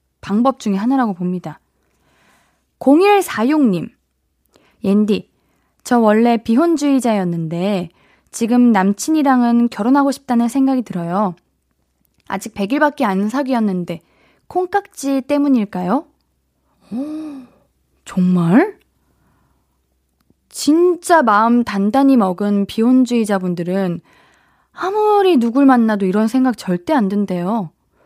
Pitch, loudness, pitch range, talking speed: 230 Hz, -16 LUFS, 190-270 Hz, 215 characters per minute